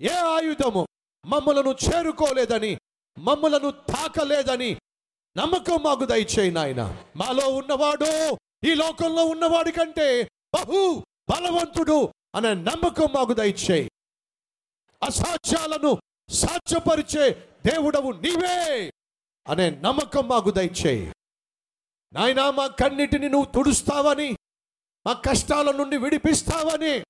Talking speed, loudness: 80 wpm, -23 LUFS